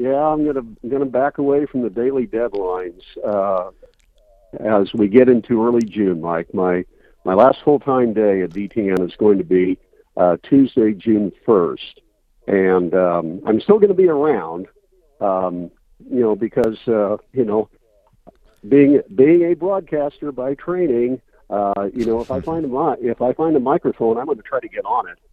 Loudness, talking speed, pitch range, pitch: -18 LUFS, 180 wpm, 100-150 Hz, 120 Hz